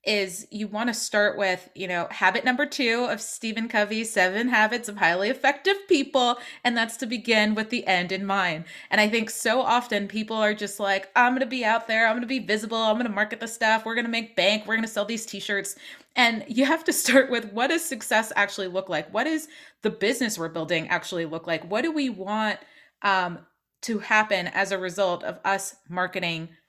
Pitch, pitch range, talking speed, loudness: 215 Hz, 195-240 Hz, 210 wpm, -24 LUFS